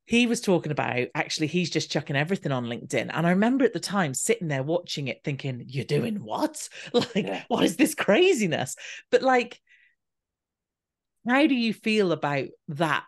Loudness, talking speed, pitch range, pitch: -25 LUFS, 175 wpm, 150-235 Hz, 175 Hz